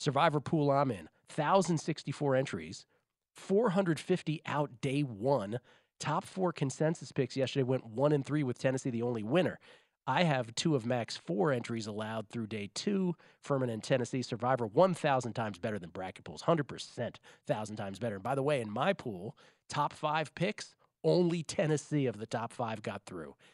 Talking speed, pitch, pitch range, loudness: 185 wpm, 140 Hz, 120-155 Hz, -33 LUFS